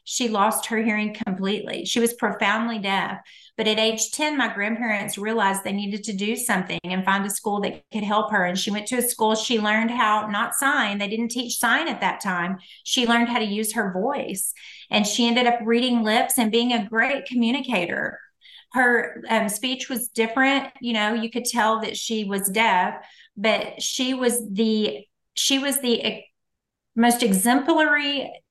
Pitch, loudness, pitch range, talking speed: 225 Hz, -22 LUFS, 210-240 Hz, 185 wpm